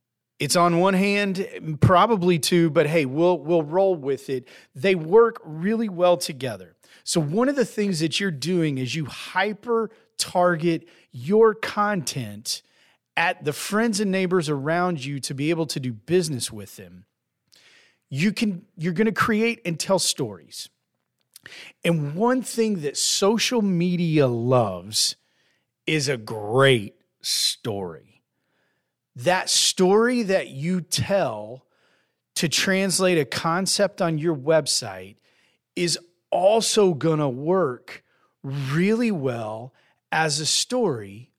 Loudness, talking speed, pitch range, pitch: -22 LUFS, 130 wpm, 140-195 Hz, 170 Hz